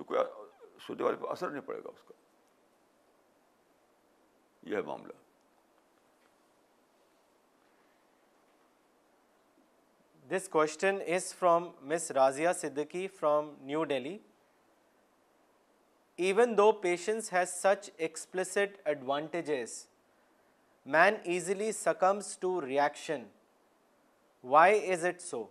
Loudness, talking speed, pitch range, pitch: -31 LUFS, 80 wpm, 155-200 Hz, 180 Hz